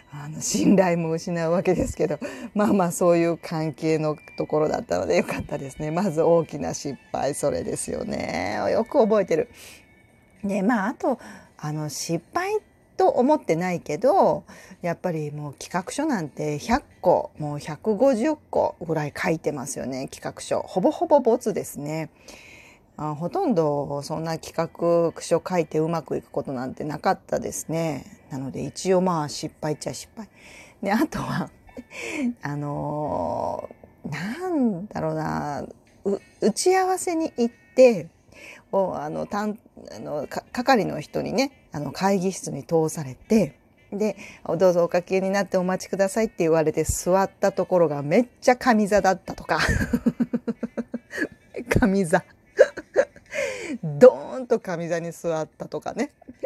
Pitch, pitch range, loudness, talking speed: 185 Hz, 155-235 Hz, -24 LUFS, 275 characters per minute